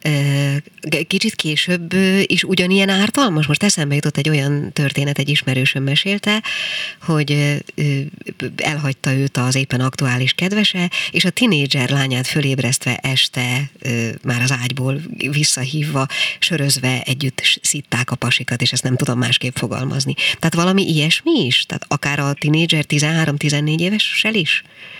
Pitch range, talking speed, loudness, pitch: 130-170 Hz, 125 wpm, -17 LUFS, 145 Hz